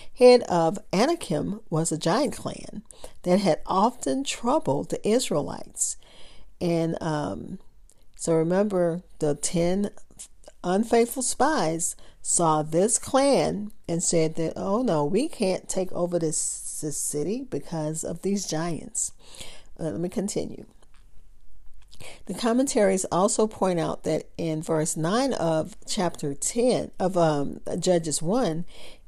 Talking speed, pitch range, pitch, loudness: 125 wpm, 160-210 Hz, 180 Hz, -25 LUFS